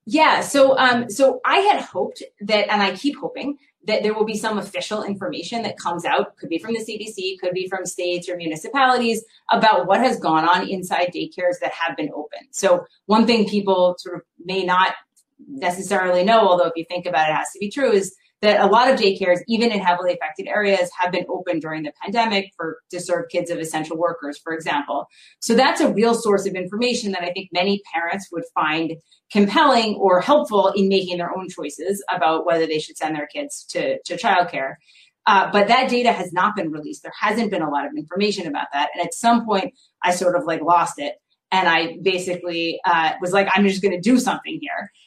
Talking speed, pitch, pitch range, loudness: 215 wpm, 190 Hz, 175-225 Hz, -20 LUFS